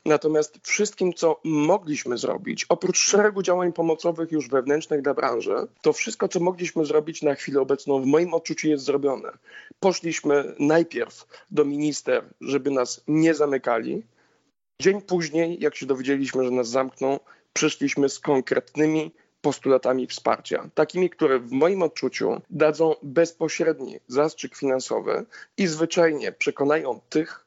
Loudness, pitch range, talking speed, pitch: -24 LUFS, 140-170 Hz, 130 wpm, 155 Hz